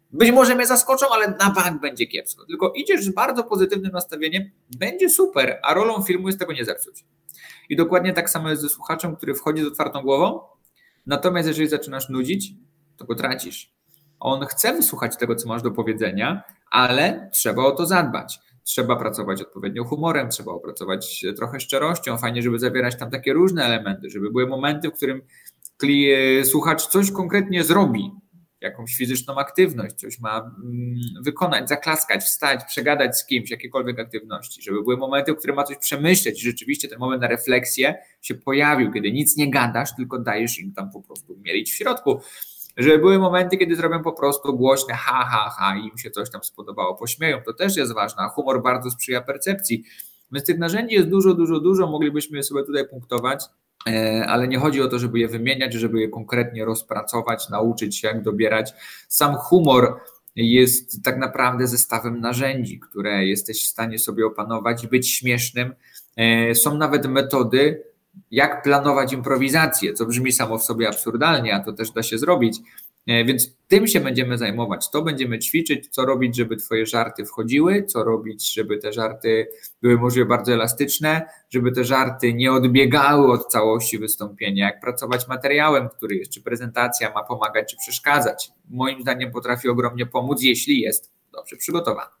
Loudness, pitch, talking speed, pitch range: -20 LUFS, 130 Hz, 170 wpm, 115-155 Hz